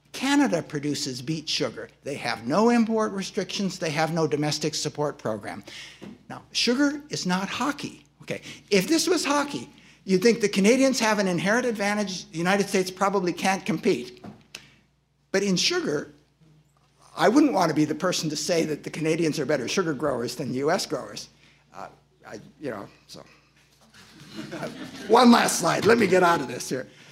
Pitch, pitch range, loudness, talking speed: 185 Hz, 150-215 Hz, -24 LUFS, 170 wpm